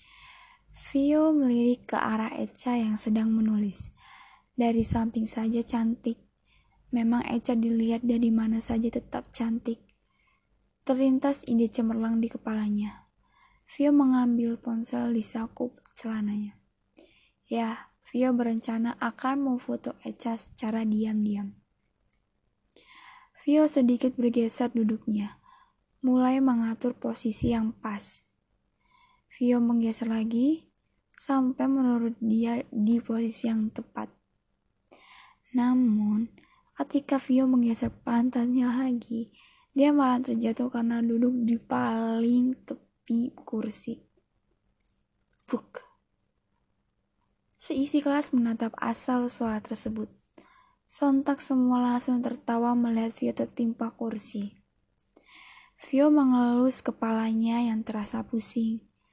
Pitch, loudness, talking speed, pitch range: 240 Hz, -27 LUFS, 95 wpm, 230-260 Hz